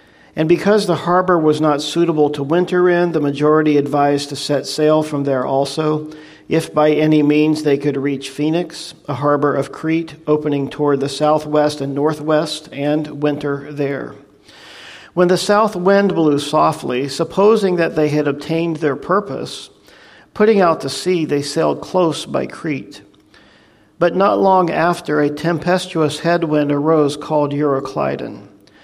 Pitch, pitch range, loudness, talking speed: 155 Hz, 145-170 Hz, -16 LUFS, 150 wpm